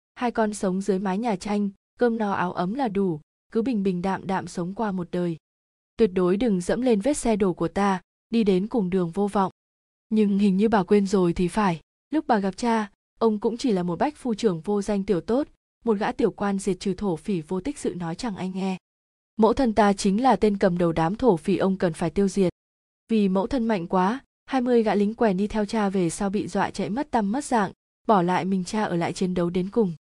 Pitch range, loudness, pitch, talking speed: 185-225 Hz, -24 LUFS, 200 Hz, 245 wpm